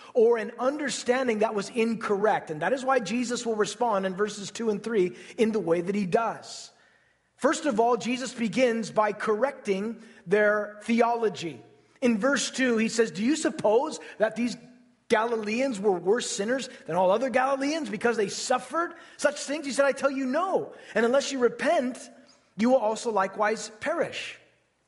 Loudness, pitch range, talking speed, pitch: -27 LUFS, 215-265 Hz, 170 wpm, 230 Hz